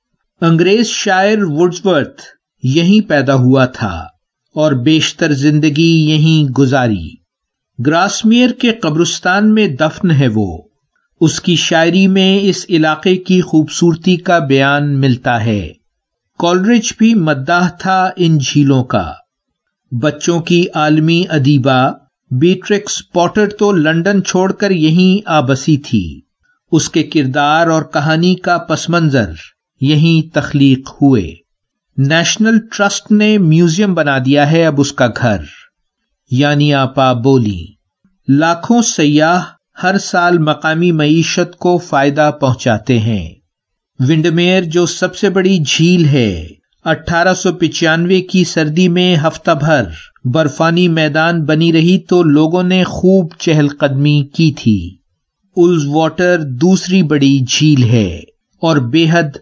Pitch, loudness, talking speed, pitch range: 160 Hz, -12 LUFS, 120 wpm, 140-180 Hz